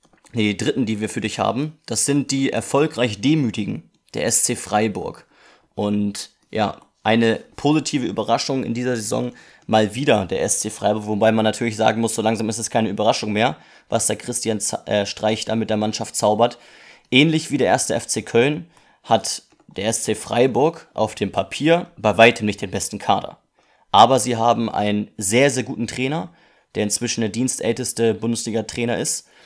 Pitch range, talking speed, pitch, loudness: 110-125 Hz, 175 wpm, 115 Hz, -20 LUFS